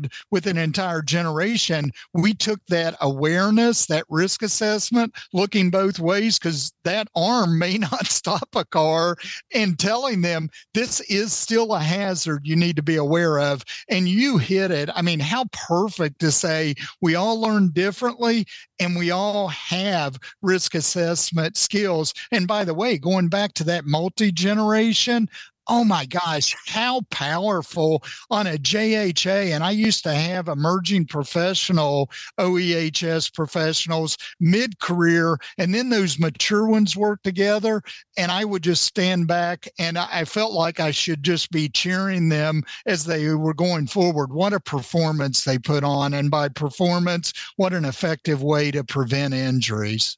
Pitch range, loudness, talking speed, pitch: 160-200 Hz, -21 LUFS, 155 wpm, 175 Hz